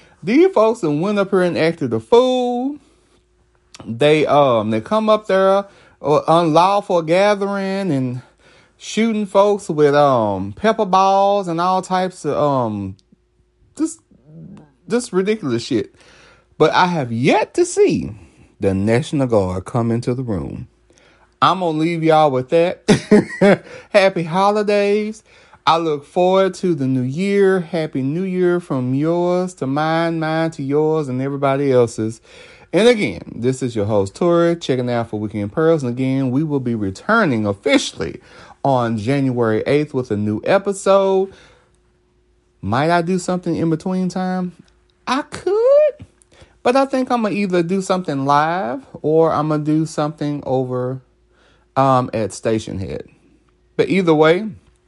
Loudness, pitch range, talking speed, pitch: -17 LUFS, 130-190 Hz, 150 wpm, 160 Hz